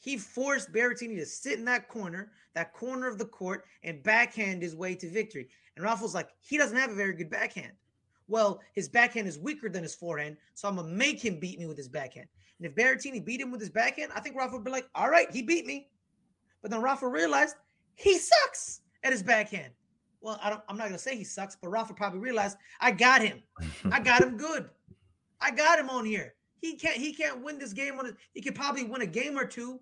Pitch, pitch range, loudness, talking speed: 225 Hz, 195-260 Hz, -29 LUFS, 235 wpm